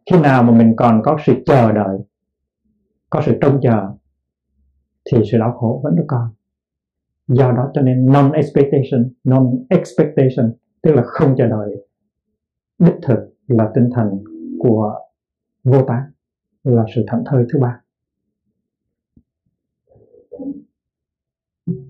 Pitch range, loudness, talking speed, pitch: 110-145 Hz, -15 LUFS, 120 wpm, 125 Hz